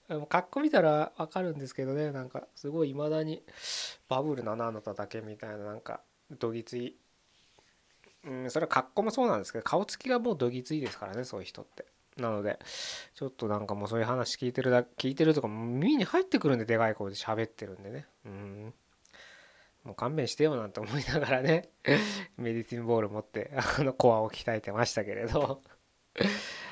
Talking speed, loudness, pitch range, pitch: 390 characters per minute, -31 LUFS, 115-155 Hz, 130 Hz